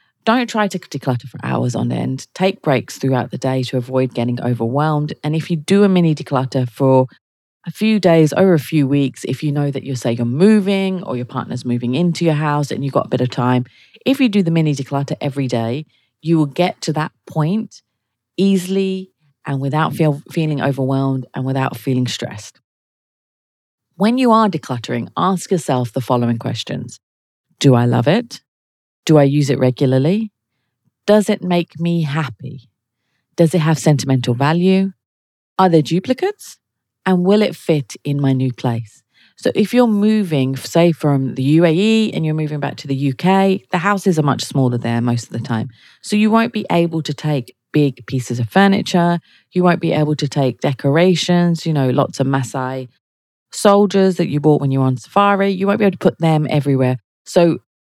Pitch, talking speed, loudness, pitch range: 145 Hz, 190 wpm, -17 LUFS, 130-180 Hz